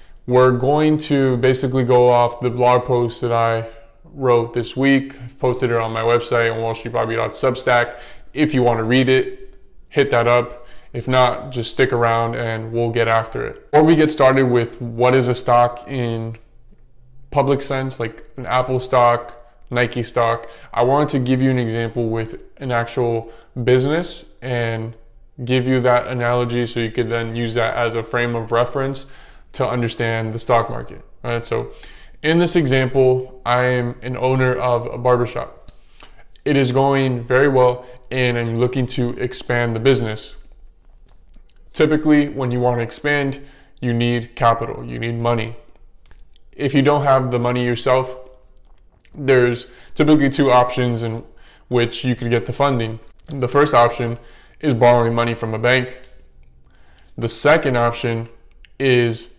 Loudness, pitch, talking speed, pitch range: -18 LUFS, 120 Hz, 160 wpm, 115-130 Hz